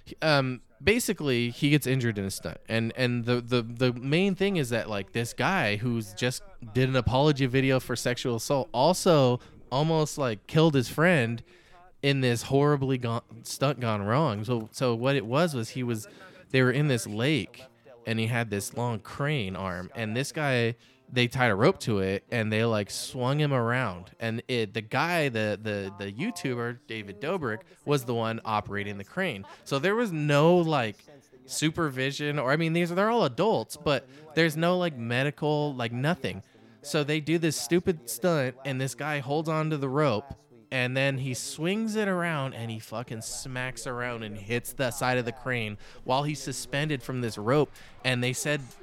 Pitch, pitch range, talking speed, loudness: 130 Hz, 115-150 Hz, 190 wpm, -28 LUFS